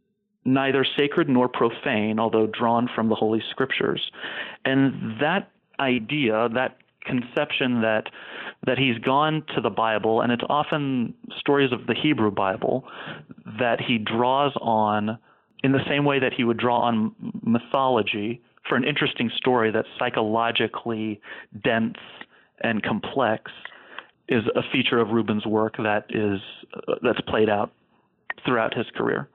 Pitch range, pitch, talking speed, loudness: 110-140 Hz, 120 Hz, 135 wpm, -24 LUFS